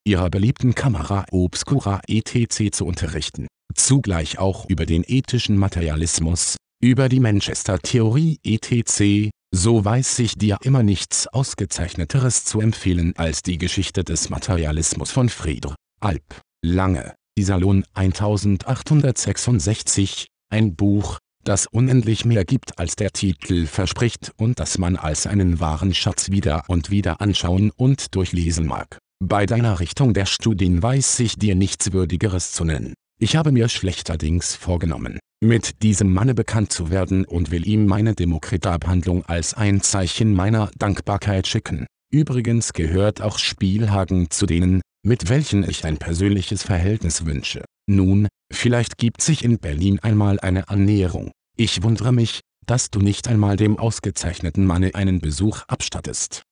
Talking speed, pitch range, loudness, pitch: 140 wpm, 90-110 Hz, -20 LUFS, 100 Hz